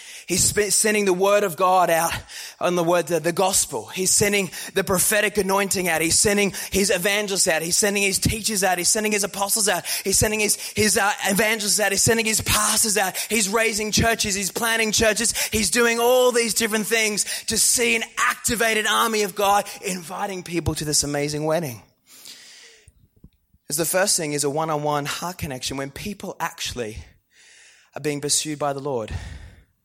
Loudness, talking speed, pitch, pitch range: -20 LUFS, 180 wpm, 200 Hz, 165-215 Hz